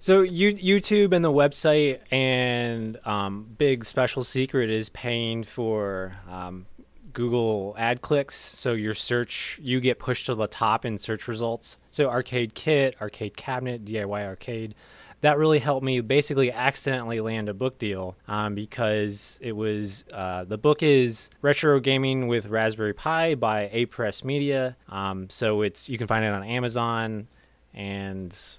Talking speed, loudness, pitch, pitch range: 155 wpm, -25 LUFS, 120 Hz, 105-135 Hz